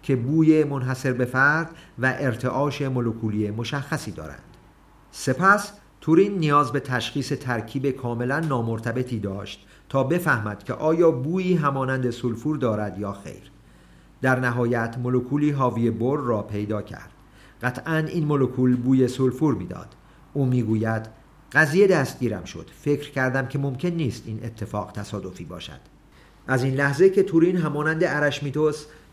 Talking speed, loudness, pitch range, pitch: 130 wpm, -23 LUFS, 115-150 Hz, 130 Hz